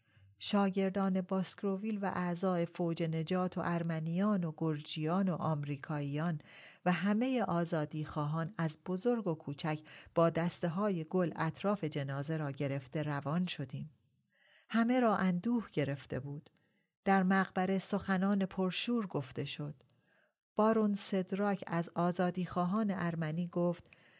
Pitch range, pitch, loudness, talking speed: 155-195 Hz, 175 Hz, -33 LUFS, 120 wpm